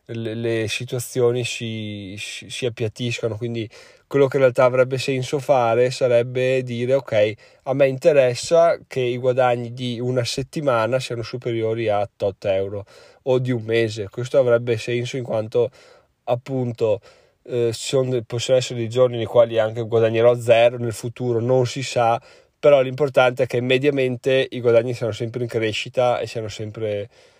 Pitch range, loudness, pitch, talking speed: 115-130 Hz, -21 LUFS, 120 Hz, 155 wpm